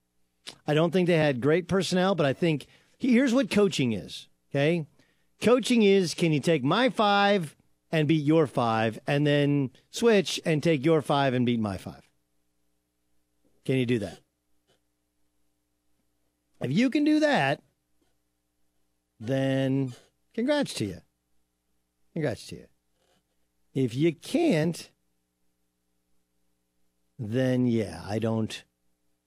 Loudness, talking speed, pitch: -26 LUFS, 125 wpm, 120 Hz